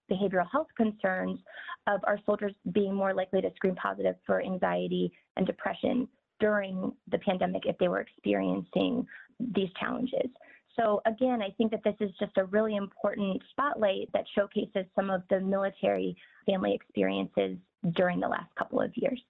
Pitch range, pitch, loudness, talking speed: 185-230 Hz, 200 Hz, -31 LUFS, 160 wpm